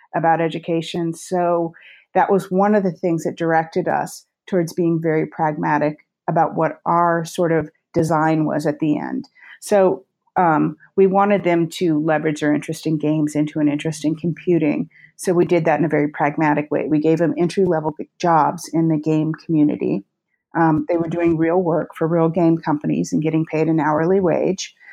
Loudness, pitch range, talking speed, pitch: -19 LUFS, 155-175 Hz, 185 wpm, 165 Hz